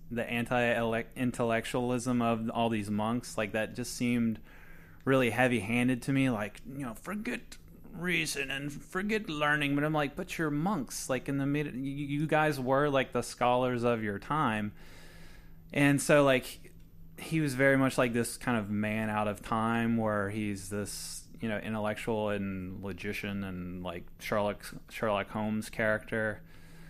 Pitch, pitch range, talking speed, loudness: 120 Hz, 105-135 Hz, 160 wpm, -31 LUFS